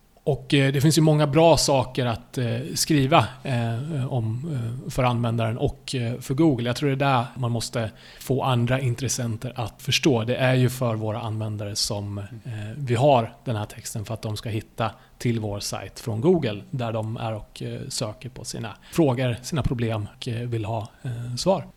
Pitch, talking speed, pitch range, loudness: 120 Hz, 170 wpm, 115-135 Hz, -24 LUFS